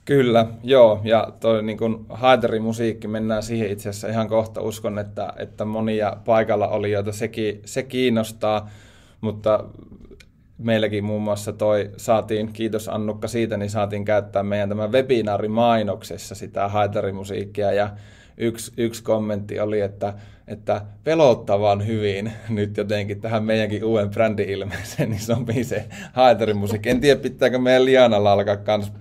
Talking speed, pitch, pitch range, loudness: 135 wpm, 110 Hz, 105-115 Hz, -21 LUFS